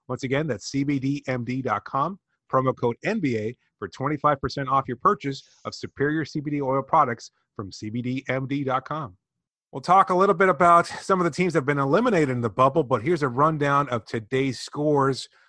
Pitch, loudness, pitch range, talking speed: 140 Hz, -23 LUFS, 130-155 Hz, 165 wpm